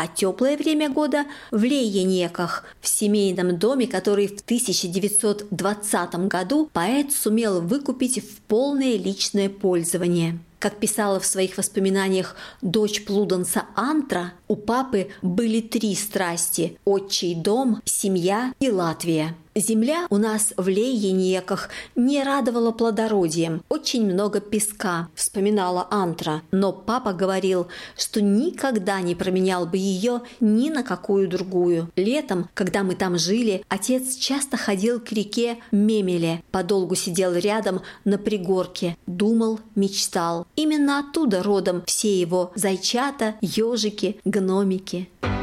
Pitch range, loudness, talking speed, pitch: 185-225 Hz, -23 LUFS, 120 wpm, 200 Hz